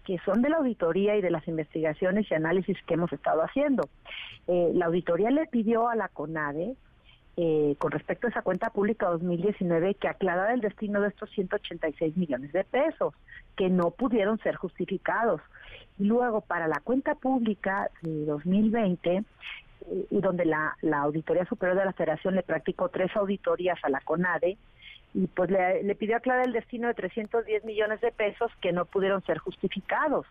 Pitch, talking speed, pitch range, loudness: 190 Hz, 170 wpm, 170-220 Hz, -28 LUFS